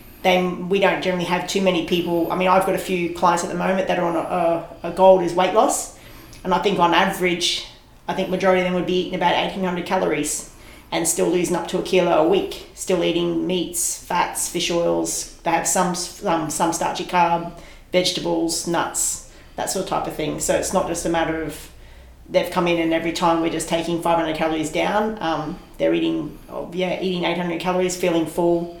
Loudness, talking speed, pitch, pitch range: -21 LUFS, 215 wpm, 175 Hz, 165-180 Hz